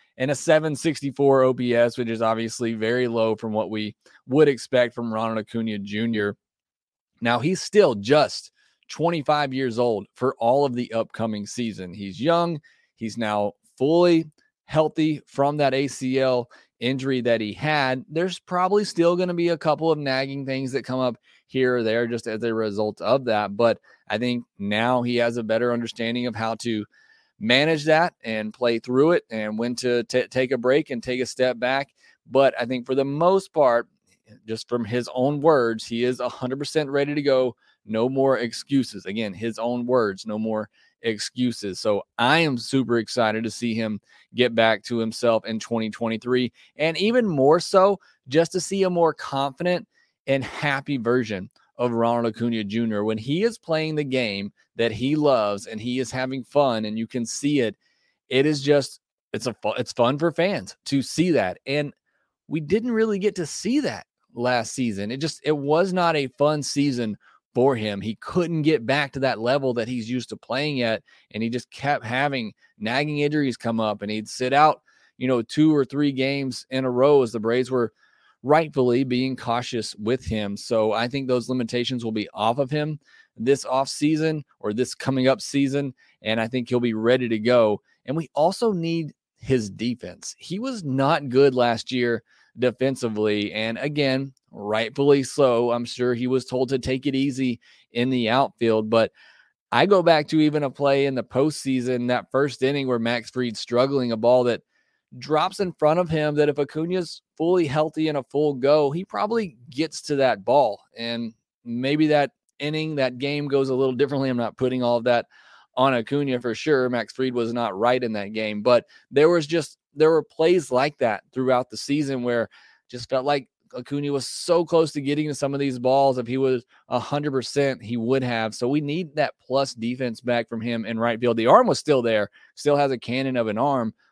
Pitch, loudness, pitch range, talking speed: 130 Hz, -23 LUFS, 115-145 Hz, 195 wpm